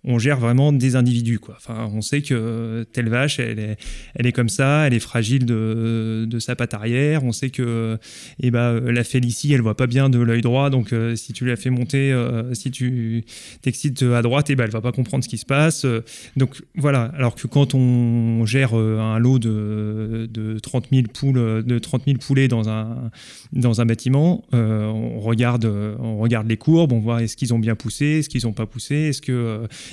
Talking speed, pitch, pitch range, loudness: 225 wpm, 120 Hz, 115-130 Hz, -20 LUFS